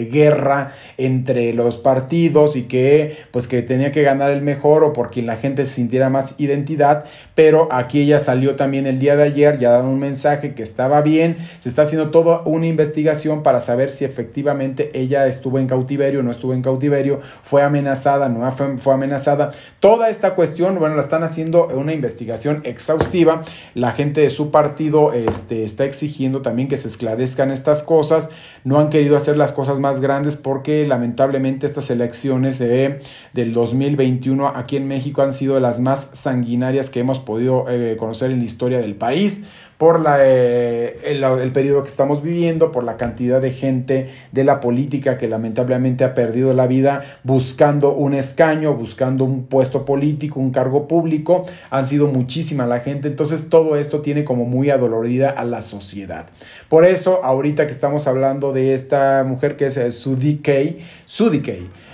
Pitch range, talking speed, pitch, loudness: 130-150 Hz, 175 wpm, 140 Hz, -17 LUFS